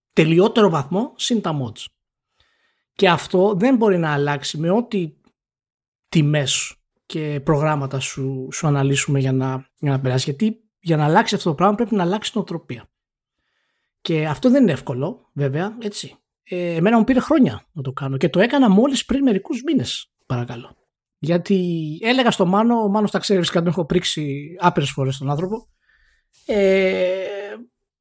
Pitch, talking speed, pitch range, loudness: 175 Hz, 160 wpm, 145-210 Hz, -19 LUFS